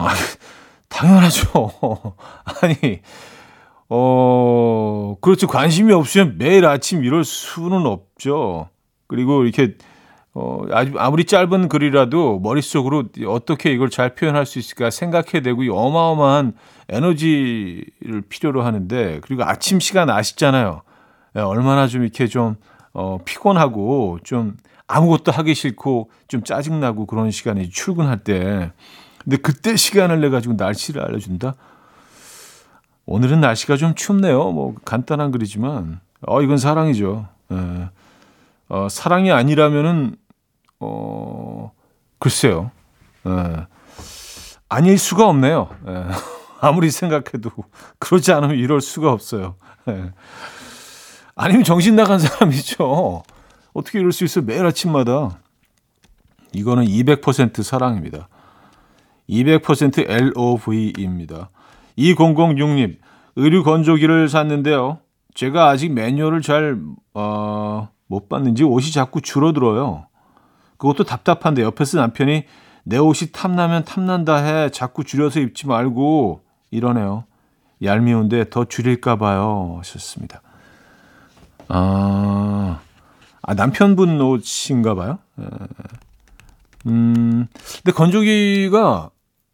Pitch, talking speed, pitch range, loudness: 130 Hz, 240 characters per minute, 110-155 Hz, -17 LUFS